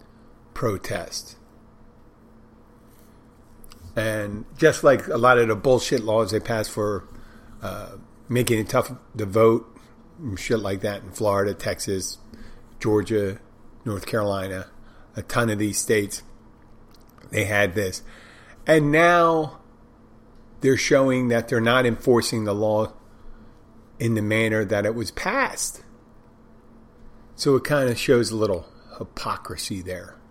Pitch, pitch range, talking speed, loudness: 115 Hz, 105-120 Hz, 125 wpm, -22 LUFS